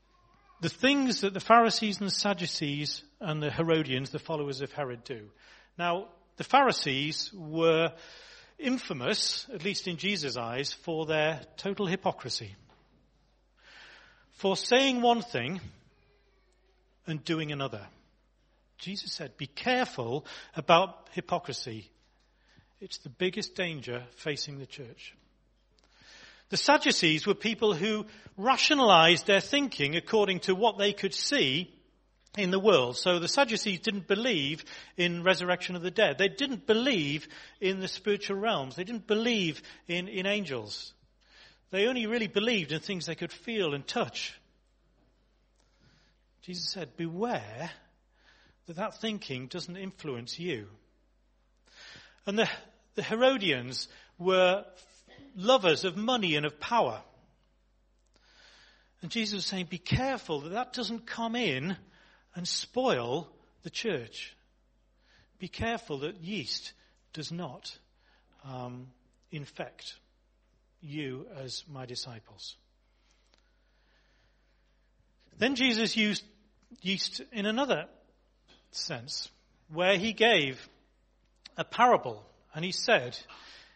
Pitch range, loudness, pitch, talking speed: 150-215 Hz, -29 LUFS, 185 Hz, 115 wpm